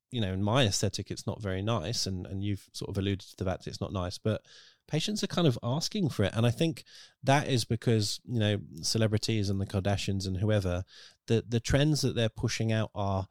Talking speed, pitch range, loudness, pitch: 230 wpm, 100-120 Hz, -30 LUFS, 110 Hz